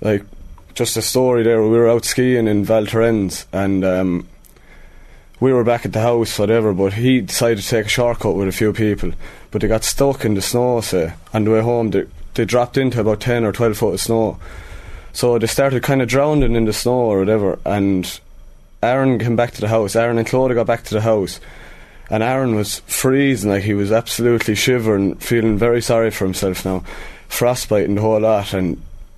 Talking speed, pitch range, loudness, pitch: 210 wpm, 100-120 Hz, -17 LUFS, 110 Hz